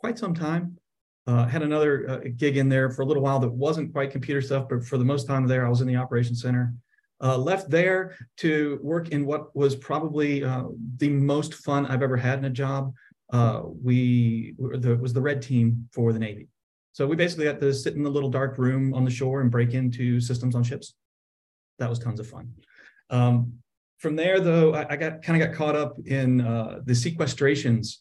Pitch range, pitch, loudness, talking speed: 125-150 Hz, 135 Hz, -25 LUFS, 220 wpm